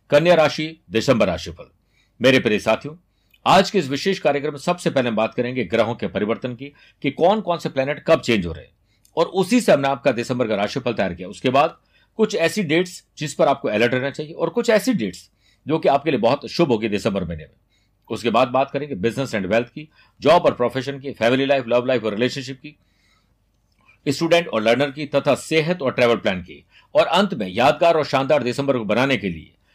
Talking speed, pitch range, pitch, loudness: 215 wpm, 115-155 Hz, 135 Hz, -20 LUFS